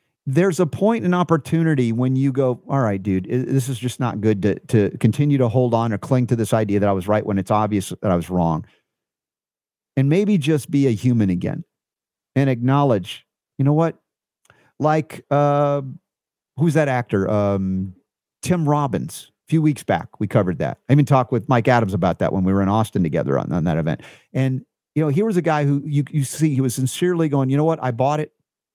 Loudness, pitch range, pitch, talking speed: -20 LUFS, 110-150 Hz, 130 Hz, 215 wpm